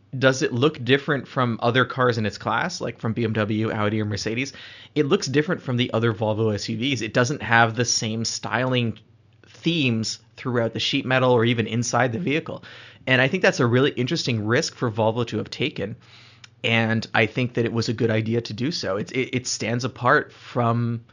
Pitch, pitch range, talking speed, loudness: 120 Hz, 115-130 Hz, 200 wpm, -23 LUFS